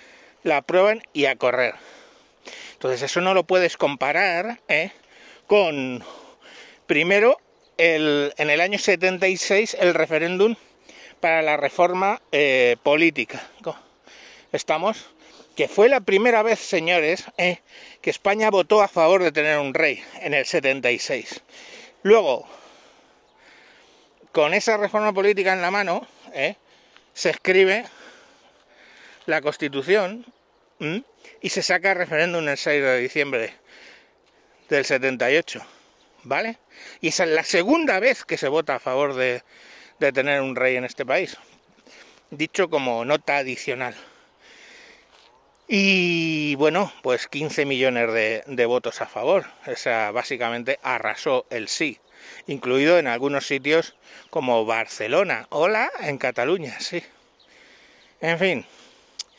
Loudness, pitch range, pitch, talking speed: -21 LUFS, 145-205 Hz, 175 Hz, 120 wpm